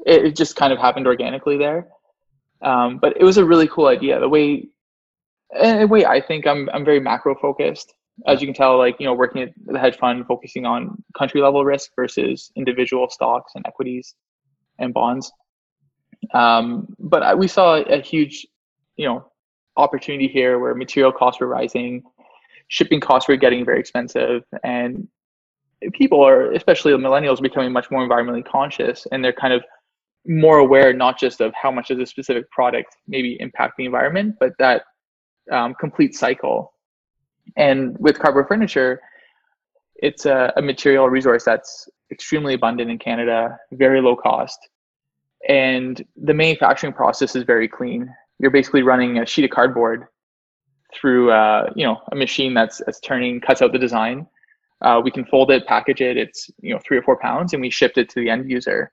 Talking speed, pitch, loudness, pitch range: 175 wpm, 135 Hz, -17 LUFS, 125-150 Hz